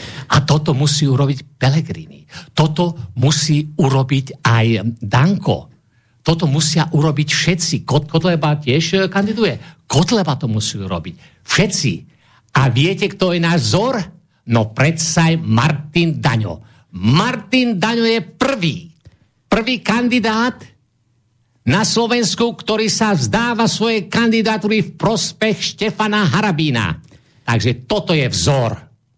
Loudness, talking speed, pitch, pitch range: -16 LUFS, 110 wpm, 155 Hz, 130-195 Hz